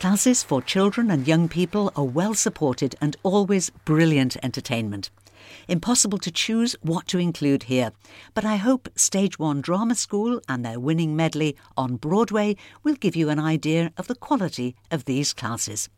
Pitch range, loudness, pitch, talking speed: 135-200 Hz, -23 LUFS, 160 Hz, 165 wpm